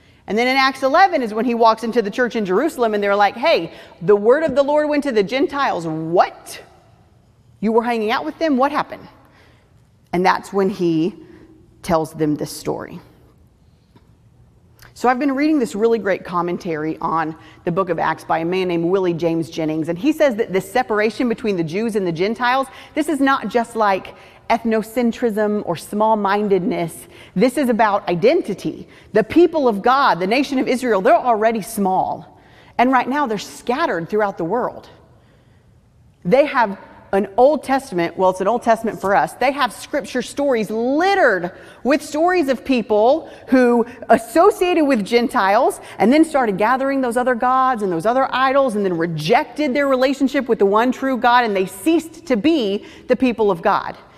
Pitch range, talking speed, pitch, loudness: 190-265 Hz, 180 wpm, 230 Hz, -18 LUFS